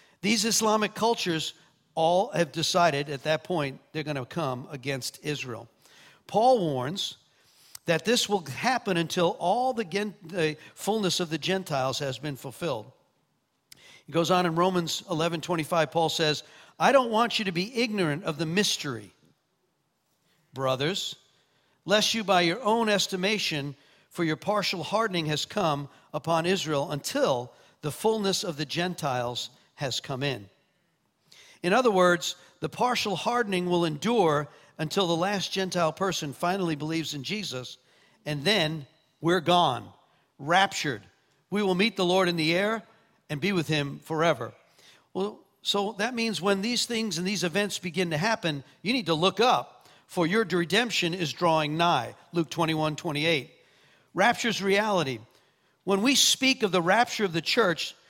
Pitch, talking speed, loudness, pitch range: 175 Hz, 155 wpm, -27 LUFS, 150-200 Hz